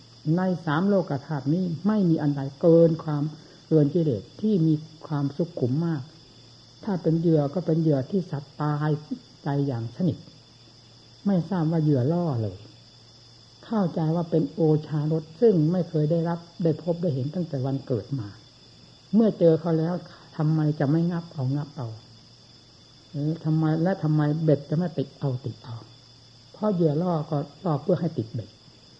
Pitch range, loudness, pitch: 130-165 Hz, -25 LUFS, 155 Hz